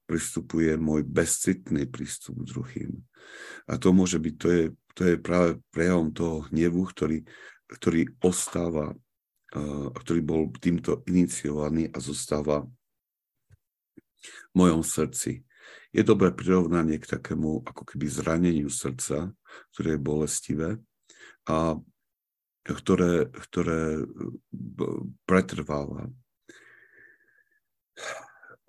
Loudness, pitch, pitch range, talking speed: -27 LUFS, 80 Hz, 75-90 Hz, 95 wpm